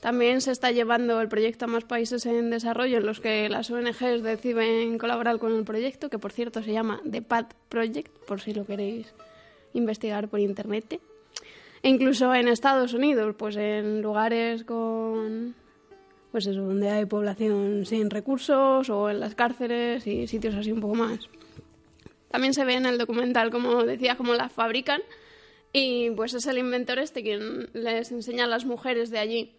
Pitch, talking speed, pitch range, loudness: 230 Hz, 175 wpm, 215-245 Hz, -26 LUFS